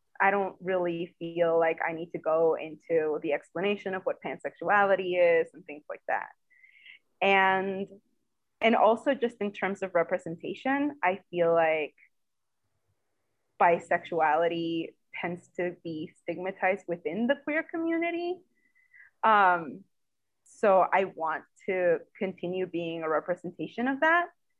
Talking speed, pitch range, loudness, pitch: 125 wpm, 165-220 Hz, -28 LUFS, 180 Hz